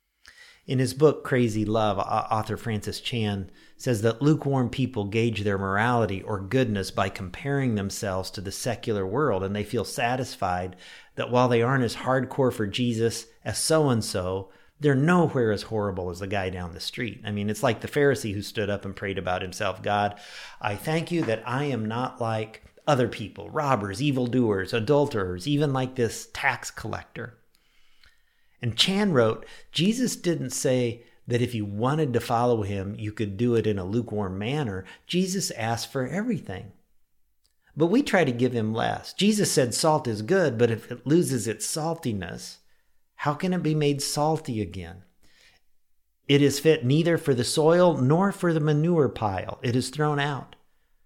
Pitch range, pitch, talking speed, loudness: 105-145 Hz, 120 Hz, 175 wpm, -26 LUFS